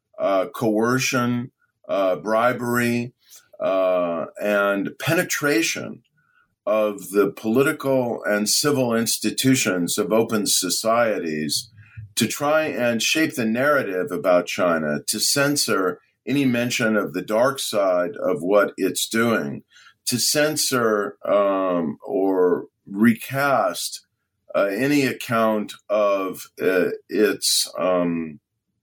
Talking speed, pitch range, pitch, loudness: 100 wpm, 100-125 Hz, 110 Hz, -21 LUFS